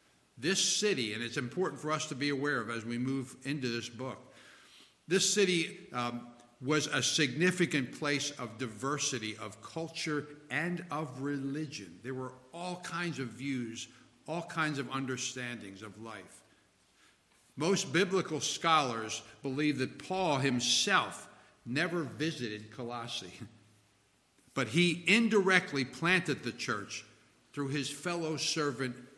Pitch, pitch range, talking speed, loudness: 140 Hz, 120-160 Hz, 130 wpm, -33 LUFS